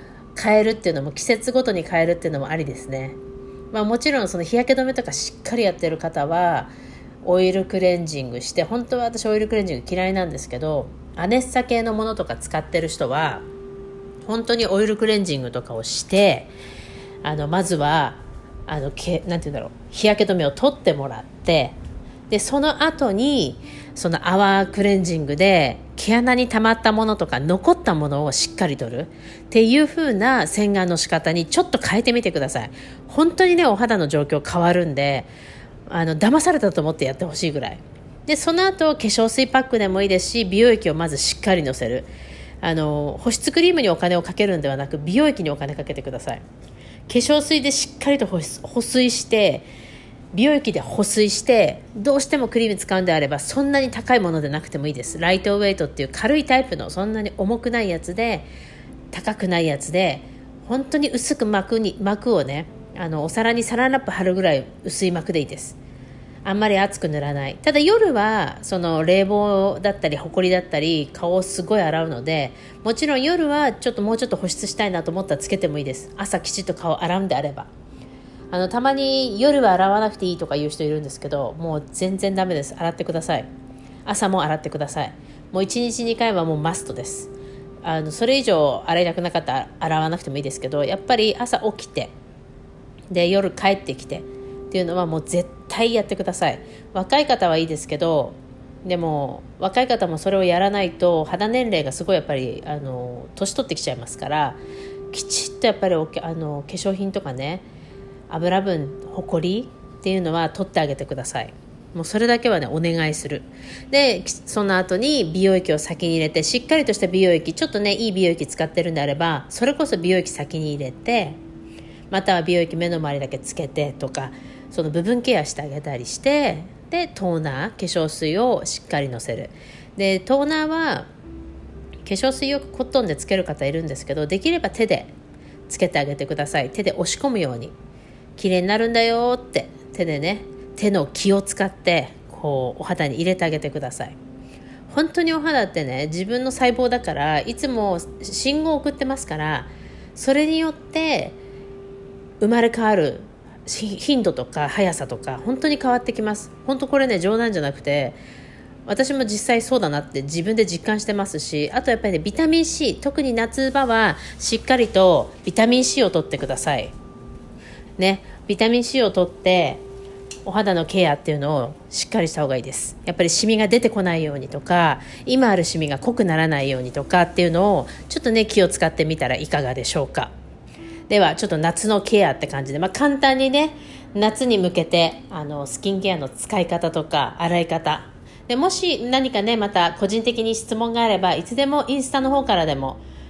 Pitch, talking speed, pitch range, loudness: 185 Hz, 380 characters per minute, 150-230 Hz, -21 LUFS